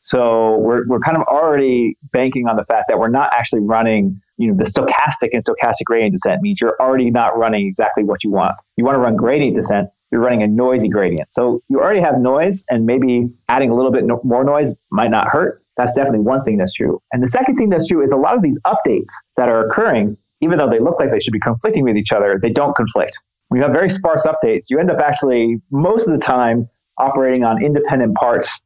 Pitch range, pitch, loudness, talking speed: 115-140 Hz, 125 Hz, -15 LUFS, 240 wpm